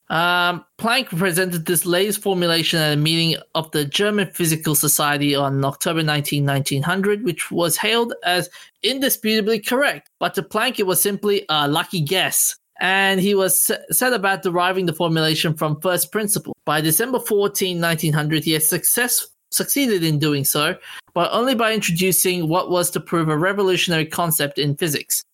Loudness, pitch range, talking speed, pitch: -19 LUFS, 160-200 Hz, 160 wpm, 175 Hz